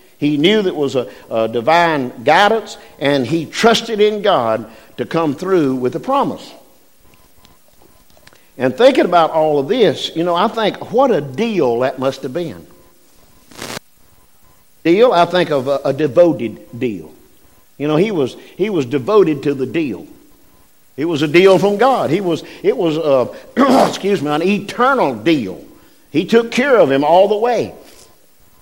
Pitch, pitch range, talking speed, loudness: 170 Hz, 140-215 Hz, 165 wpm, -15 LUFS